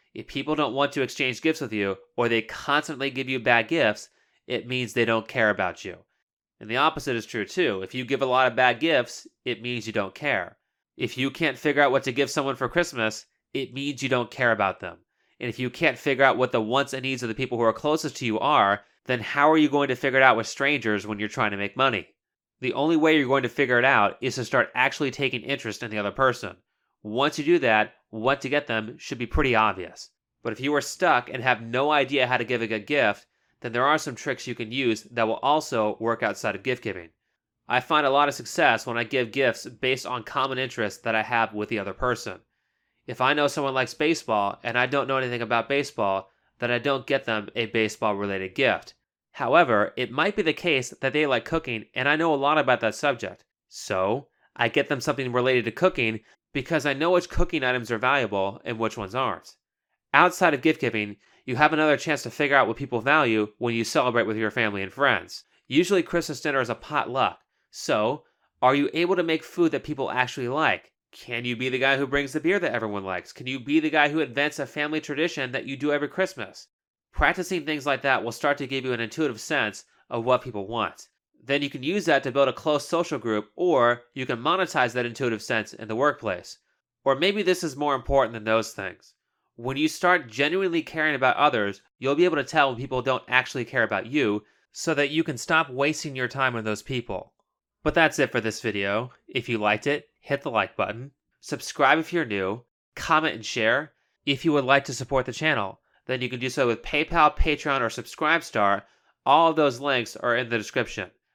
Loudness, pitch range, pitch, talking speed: -24 LUFS, 115-145 Hz, 130 Hz, 230 wpm